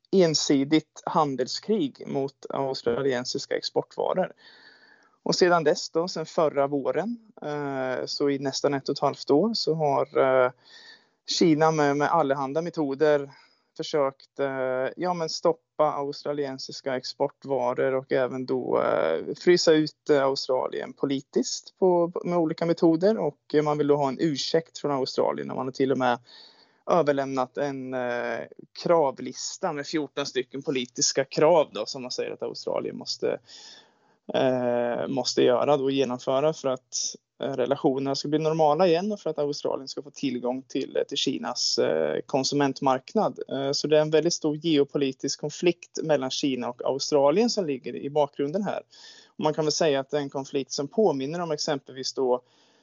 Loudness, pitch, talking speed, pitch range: -26 LUFS, 145 Hz, 145 wpm, 135-160 Hz